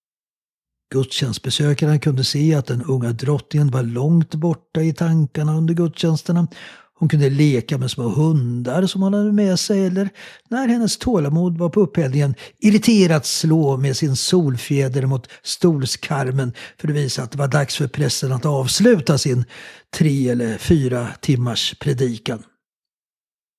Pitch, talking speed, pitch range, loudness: 150 Hz, 140 wpm, 130-170 Hz, -19 LUFS